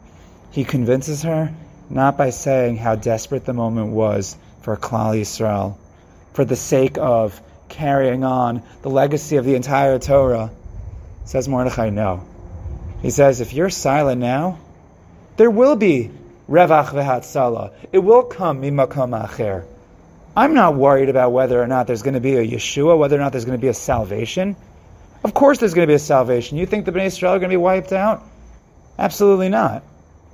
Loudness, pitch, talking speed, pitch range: -17 LUFS, 130 Hz, 170 wpm, 110-150 Hz